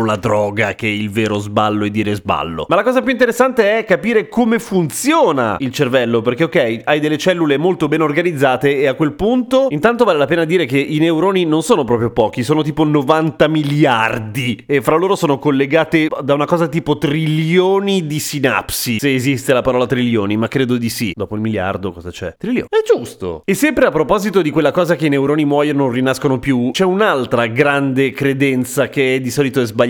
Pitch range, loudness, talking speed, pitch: 125-165 Hz, -15 LUFS, 205 wpm, 145 Hz